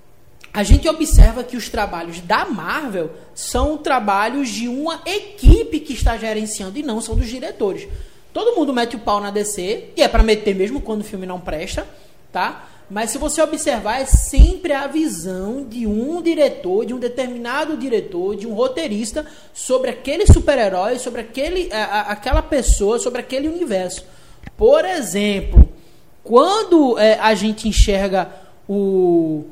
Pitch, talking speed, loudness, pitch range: 245 Hz, 155 wpm, -18 LUFS, 210-300 Hz